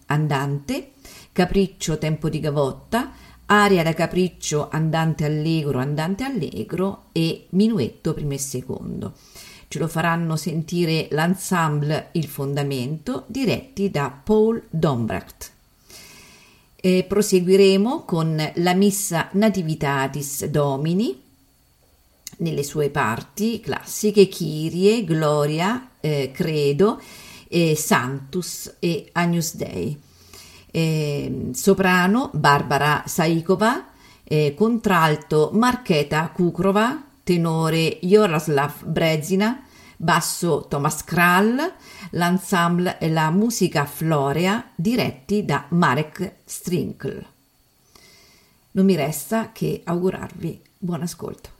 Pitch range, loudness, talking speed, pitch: 150-195 Hz, -21 LUFS, 85 wpm, 165 Hz